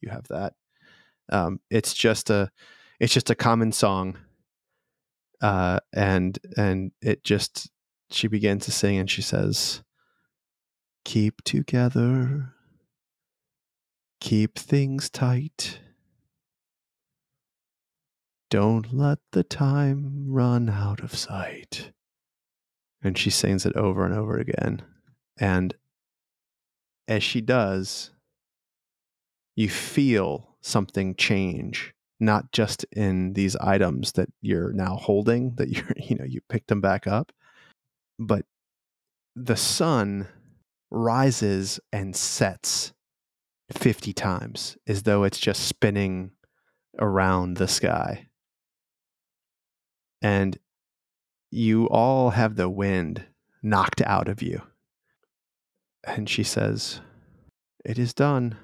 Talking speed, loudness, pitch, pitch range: 105 wpm, -25 LUFS, 105 Hz, 95-120 Hz